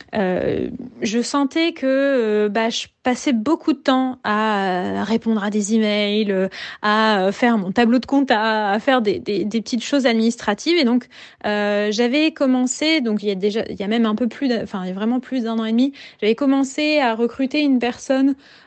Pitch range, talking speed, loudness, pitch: 215-270 Hz, 205 wpm, -19 LUFS, 235 Hz